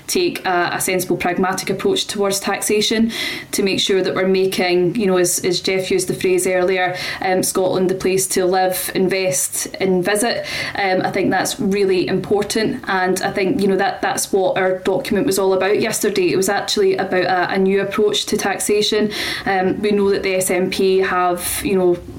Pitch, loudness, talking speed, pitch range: 190 Hz, -17 LUFS, 195 wpm, 185-205 Hz